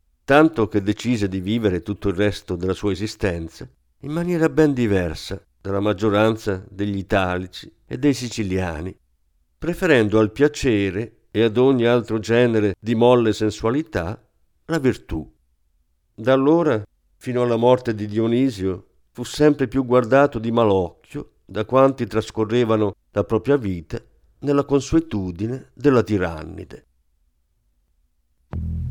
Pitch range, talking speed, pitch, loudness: 95-125 Hz, 120 wpm, 110 Hz, -20 LUFS